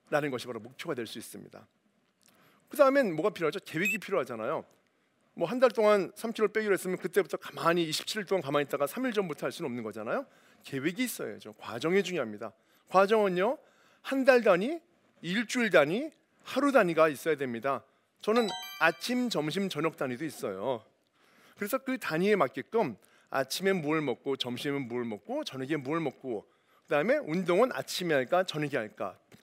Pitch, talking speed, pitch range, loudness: 180 Hz, 355 characters per minute, 145-220 Hz, -30 LUFS